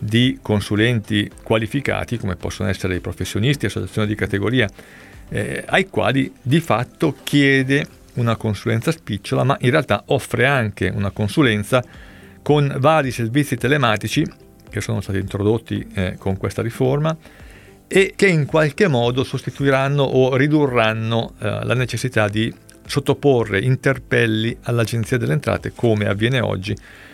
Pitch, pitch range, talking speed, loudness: 115 Hz, 105-135 Hz, 130 wpm, -19 LUFS